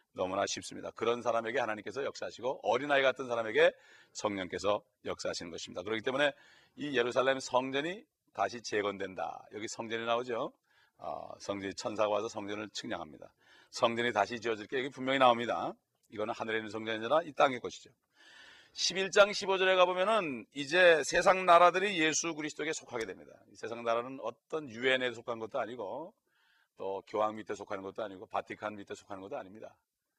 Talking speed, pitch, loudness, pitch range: 400 characters per minute, 120 Hz, -32 LUFS, 105-145 Hz